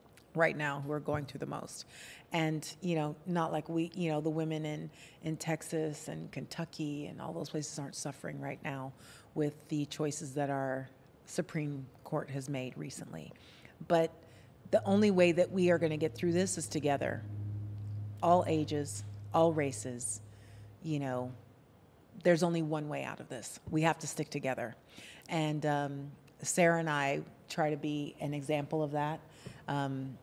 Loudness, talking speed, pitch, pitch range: -35 LUFS, 170 wpm, 150 Hz, 140-160 Hz